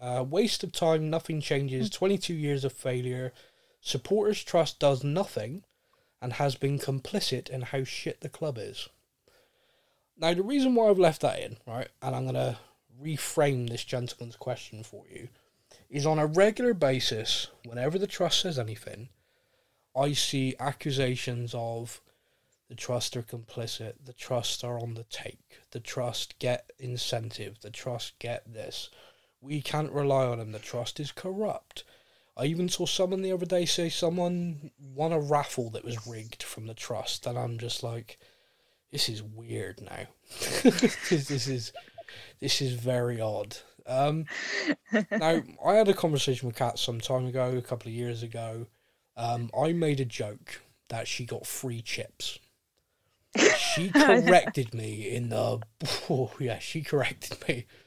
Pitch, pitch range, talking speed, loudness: 130 Hz, 120-165 Hz, 160 wpm, -29 LUFS